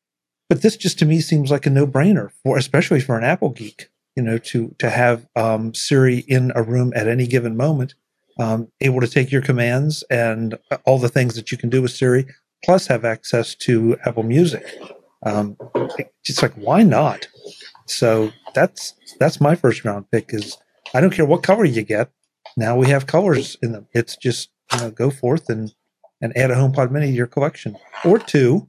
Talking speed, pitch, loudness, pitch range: 200 wpm, 125 Hz, -18 LUFS, 115-145 Hz